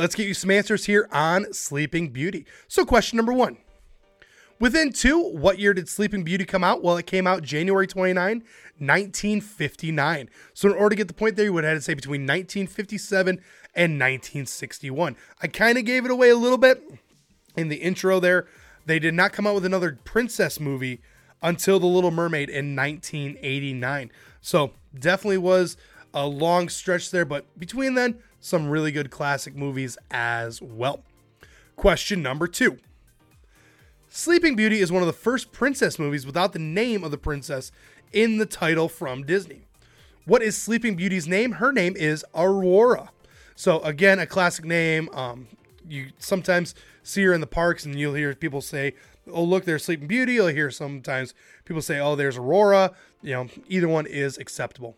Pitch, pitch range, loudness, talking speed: 175 Hz, 145-200 Hz, -23 LUFS, 175 wpm